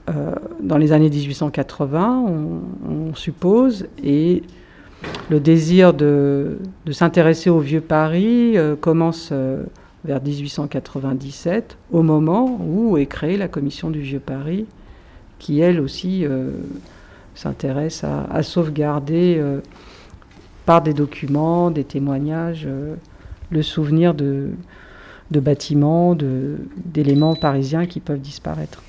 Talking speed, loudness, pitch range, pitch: 120 wpm, -19 LUFS, 140-170 Hz, 150 Hz